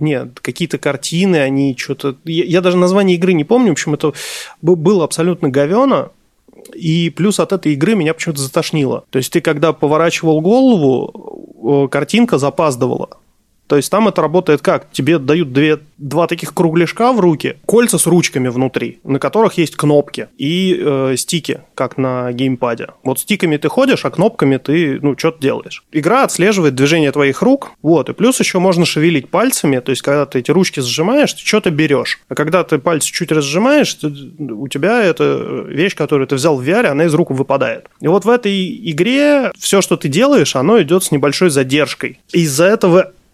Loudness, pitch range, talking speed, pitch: -14 LUFS, 145-185 Hz, 180 wpm, 165 Hz